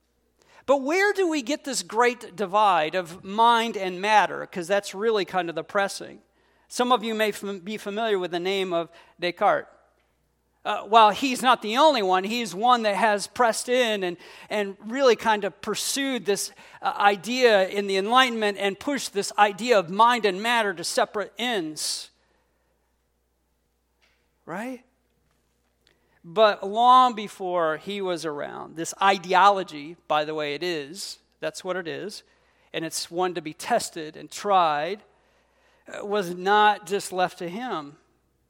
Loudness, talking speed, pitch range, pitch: -23 LUFS, 155 wpm, 175-230 Hz, 200 Hz